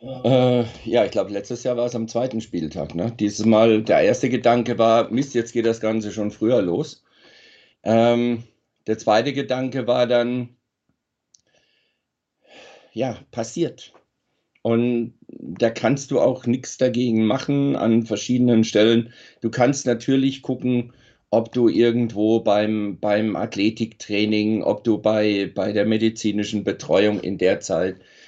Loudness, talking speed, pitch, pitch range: -21 LUFS, 135 wpm, 115 Hz, 105-120 Hz